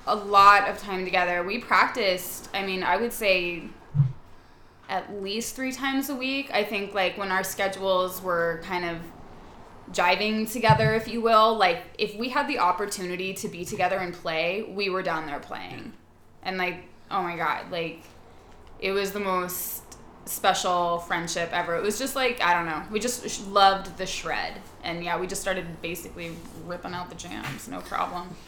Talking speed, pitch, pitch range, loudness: 180 wpm, 185 Hz, 175-205 Hz, -26 LUFS